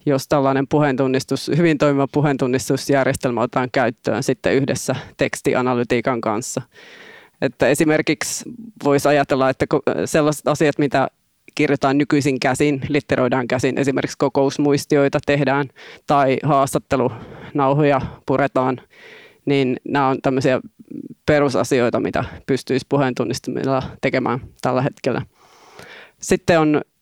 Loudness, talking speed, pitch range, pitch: -19 LUFS, 95 wpm, 130-150 Hz, 140 Hz